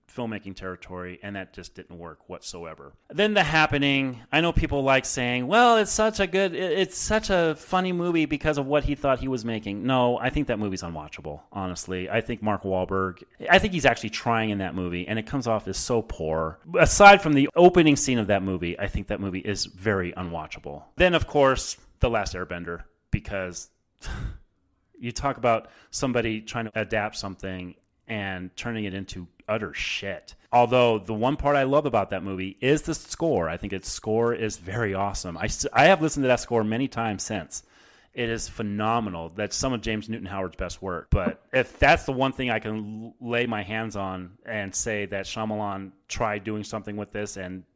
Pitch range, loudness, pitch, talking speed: 95-135 Hz, -24 LUFS, 110 Hz, 200 wpm